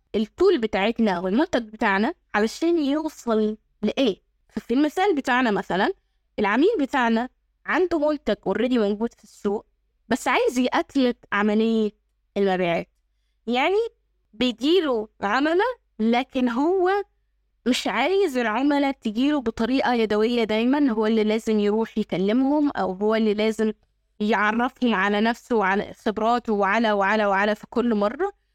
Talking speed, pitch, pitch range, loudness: 120 wpm, 230 Hz, 210-275 Hz, -23 LUFS